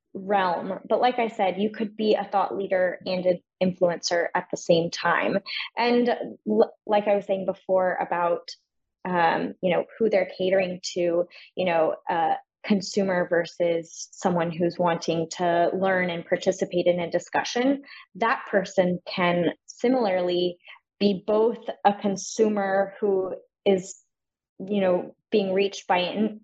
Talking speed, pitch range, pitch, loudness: 150 wpm, 175-210 Hz, 190 Hz, -25 LUFS